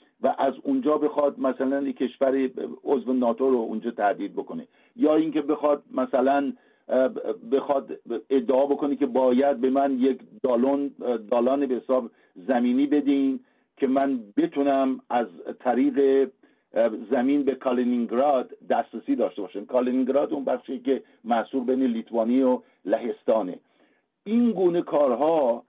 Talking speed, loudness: 125 wpm, -24 LUFS